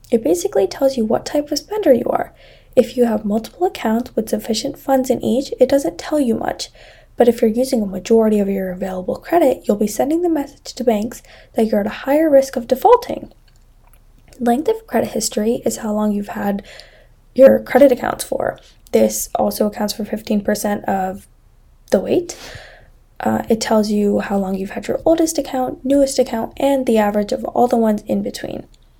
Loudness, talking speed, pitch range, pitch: -17 LUFS, 190 wpm, 215-270 Hz, 240 Hz